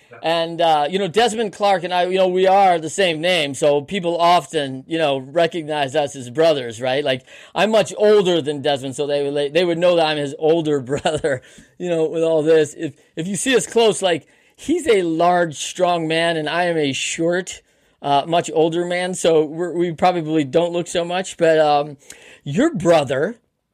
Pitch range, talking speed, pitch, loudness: 150-180 Hz, 200 wpm, 165 Hz, -18 LUFS